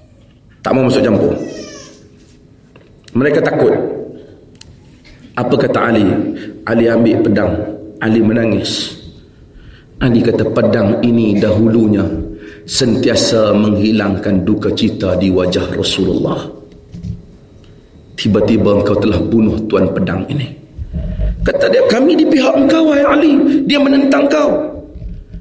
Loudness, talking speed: -13 LUFS, 105 wpm